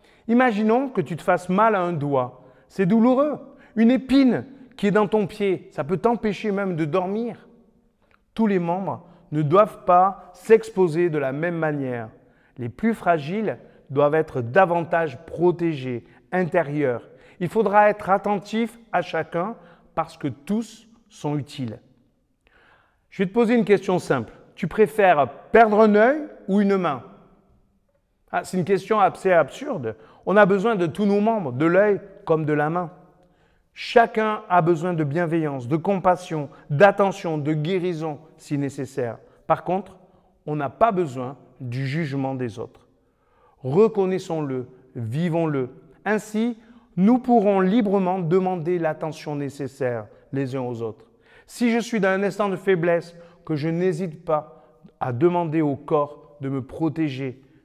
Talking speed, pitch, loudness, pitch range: 150 wpm, 180 Hz, -22 LUFS, 150-205 Hz